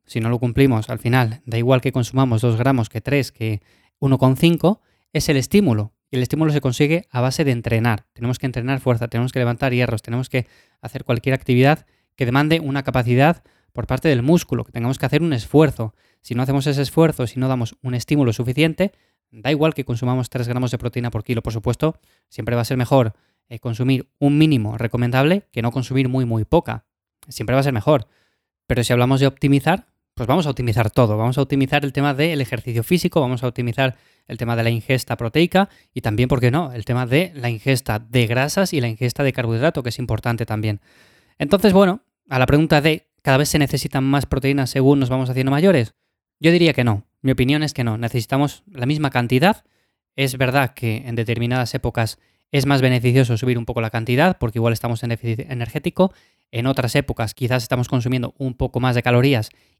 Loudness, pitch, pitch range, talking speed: -19 LUFS, 130 Hz, 120-140 Hz, 210 wpm